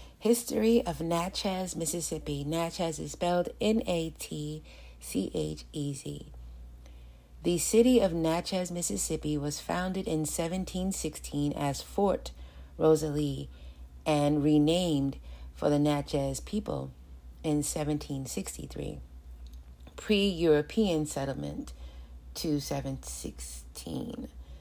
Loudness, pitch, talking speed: -30 LUFS, 145 Hz, 95 wpm